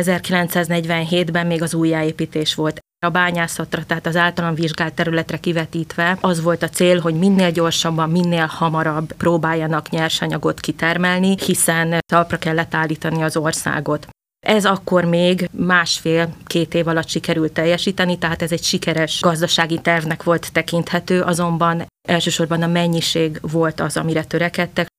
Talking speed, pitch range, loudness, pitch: 130 wpm, 160-175 Hz, -18 LUFS, 170 Hz